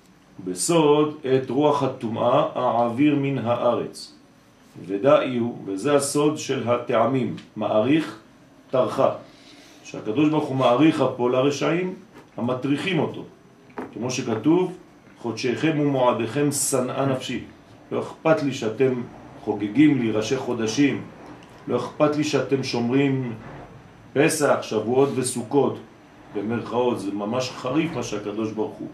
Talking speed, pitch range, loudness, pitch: 110 wpm, 120-145 Hz, -23 LUFS, 130 Hz